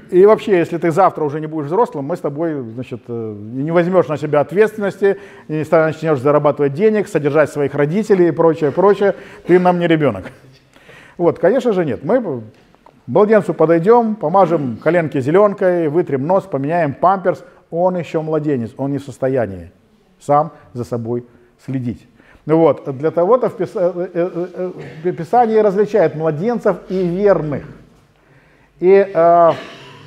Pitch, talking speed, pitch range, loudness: 165 Hz, 135 wpm, 145-185 Hz, -16 LUFS